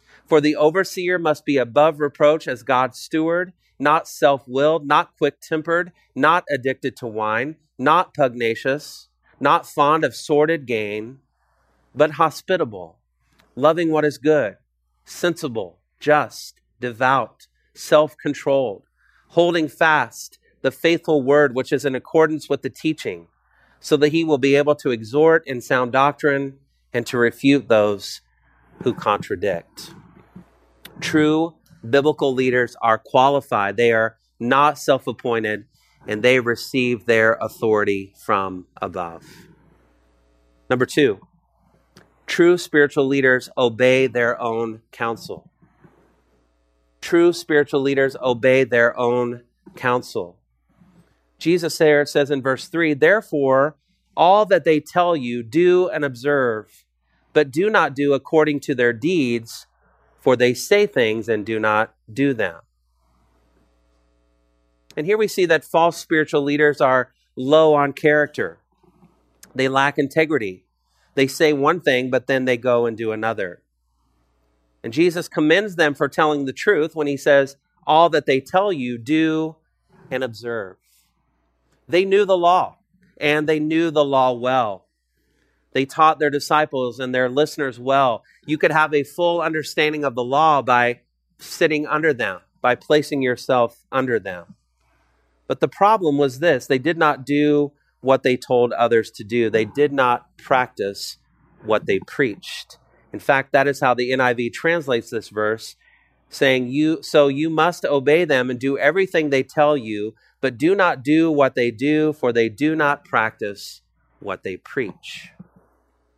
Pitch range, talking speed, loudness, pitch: 115-155 Hz, 140 wpm, -19 LUFS, 135 Hz